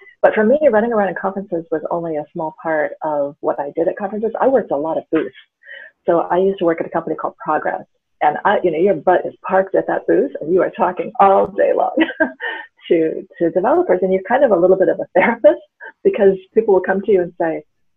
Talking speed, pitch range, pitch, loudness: 245 wpm, 165-235 Hz, 190 Hz, -17 LUFS